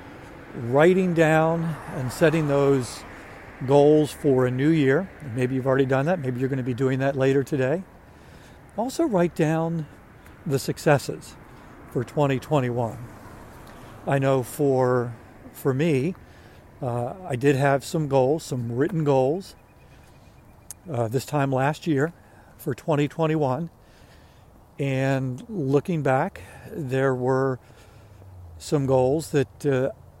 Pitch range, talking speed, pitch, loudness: 125-155 Hz, 120 wpm, 135 Hz, -24 LUFS